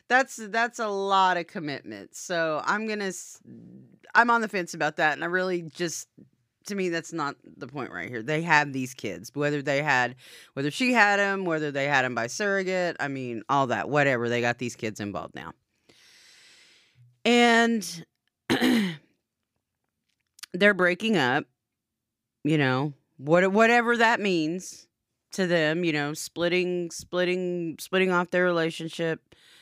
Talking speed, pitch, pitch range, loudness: 150 wpm, 165 Hz, 140-190 Hz, -25 LUFS